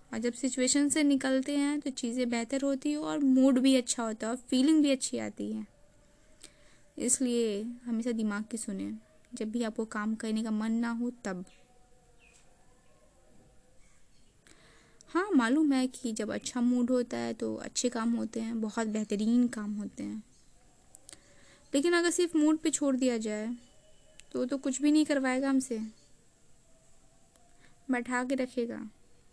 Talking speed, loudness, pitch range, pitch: 150 wpm, -30 LUFS, 225-270 Hz, 245 Hz